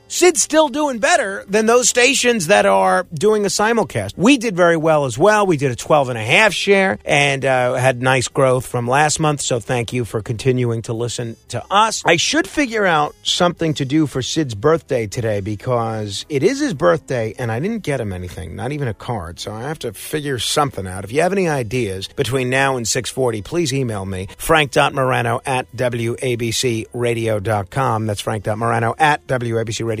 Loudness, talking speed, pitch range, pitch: -17 LUFS, 190 wpm, 115-160 Hz, 130 Hz